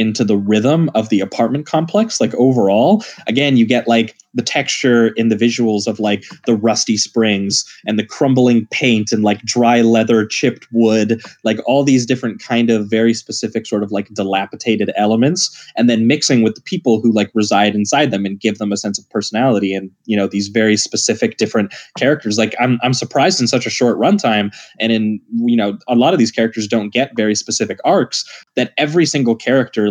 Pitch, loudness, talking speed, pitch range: 115 Hz, -15 LUFS, 200 wpm, 105-125 Hz